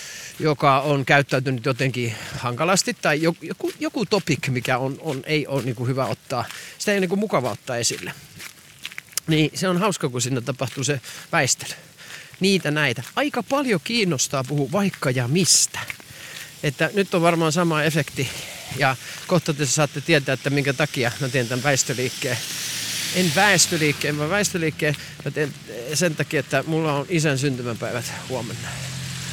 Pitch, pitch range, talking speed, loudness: 150 Hz, 135-170 Hz, 155 wpm, -22 LUFS